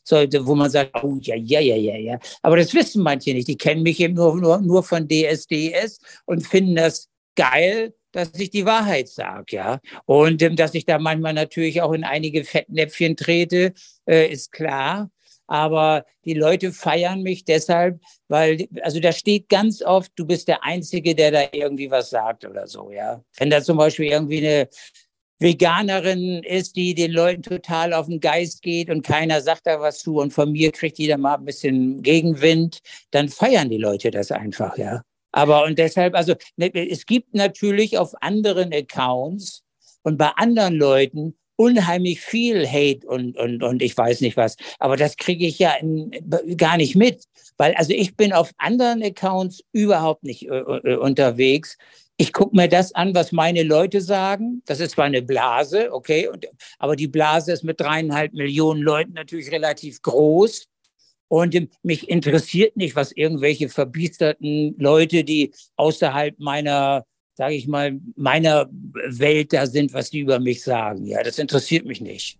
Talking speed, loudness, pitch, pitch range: 175 wpm, -19 LUFS, 160 Hz, 145-175 Hz